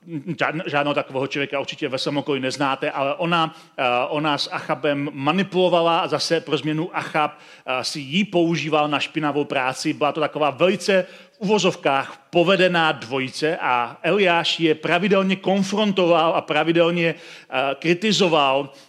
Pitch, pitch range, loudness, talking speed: 155 Hz, 145-175 Hz, -21 LUFS, 125 wpm